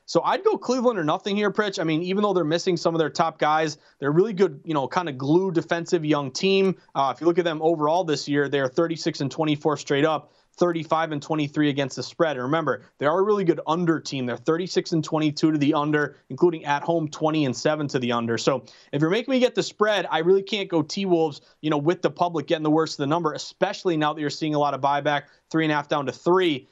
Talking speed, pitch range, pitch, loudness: 265 wpm, 145-175 Hz, 160 Hz, -23 LUFS